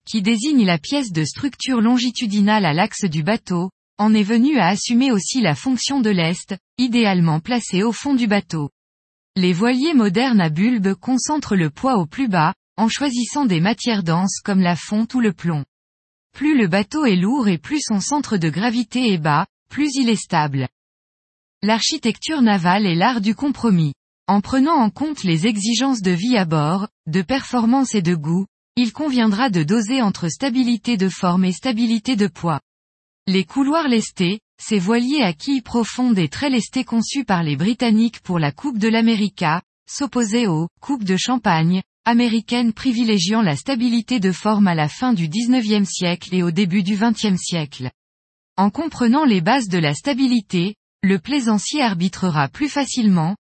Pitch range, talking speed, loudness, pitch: 180-245 Hz, 175 wpm, -19 LUFS, 215 Hz